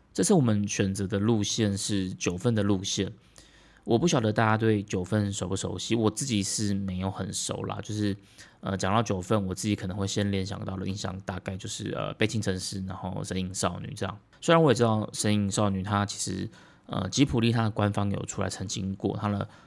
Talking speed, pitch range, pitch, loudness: 315 characters per minute, 95-110 Hz, 100 Hz, -28 LUFS